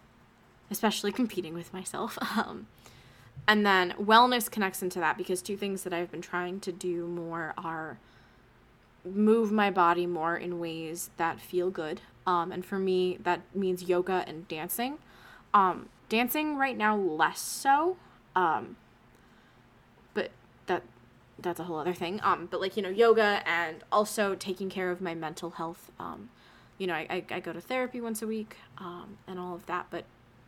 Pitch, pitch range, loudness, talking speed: 180 Hz, 170-205 Hz, -30 LUFS, 170 wpm